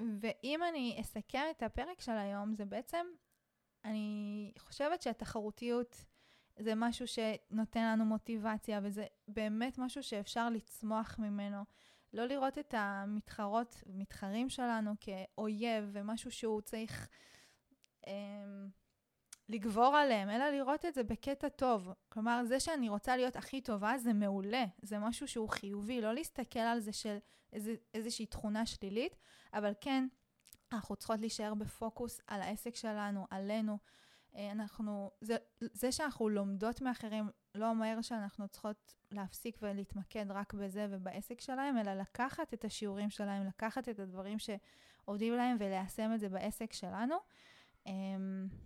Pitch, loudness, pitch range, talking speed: 220 Hz, -39 LUFS, 205-240 Hz, 130 wpm